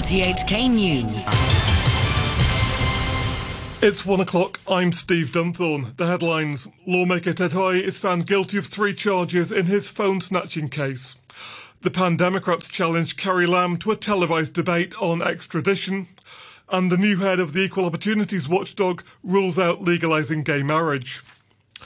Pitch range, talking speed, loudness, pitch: 165-190 Hz, 130 wpm, -21 LUFS, 180 Hz